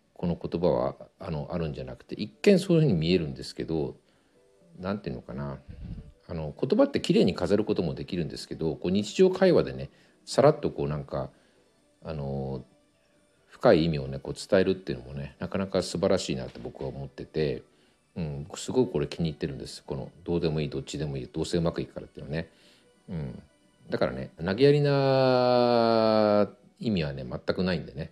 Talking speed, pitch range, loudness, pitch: 340 characters per minute, 70-120 Hz, -27 LUFS, 85 Hz